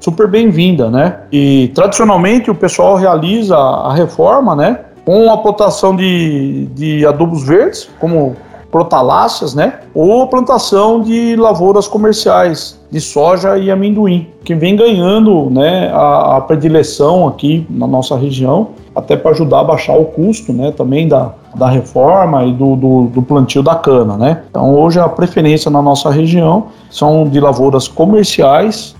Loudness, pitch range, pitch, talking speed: -10 LUFS, 140-200 Hz, 165 Hz, 150 wpm